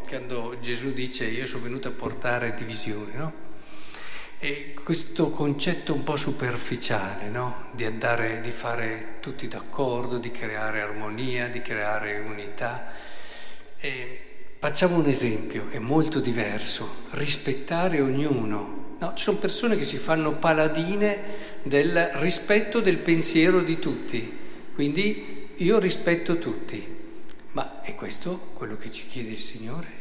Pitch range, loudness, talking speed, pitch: 120-165 Hz, -26 LUFS, 130 wpm, 135 Hz